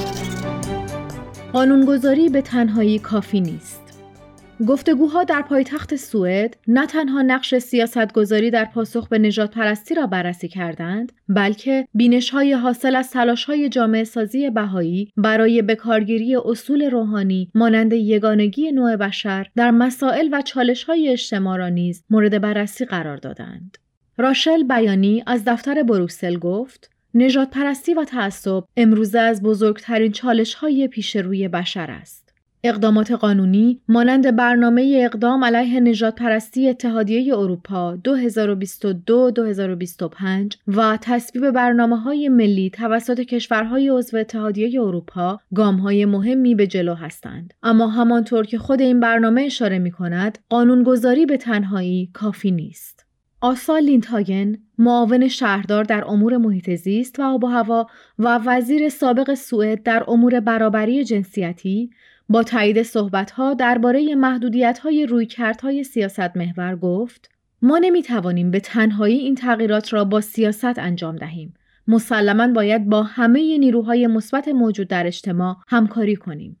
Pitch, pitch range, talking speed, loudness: 225 Hz, 200-250 Hz, 130 wpm, -18 LUFS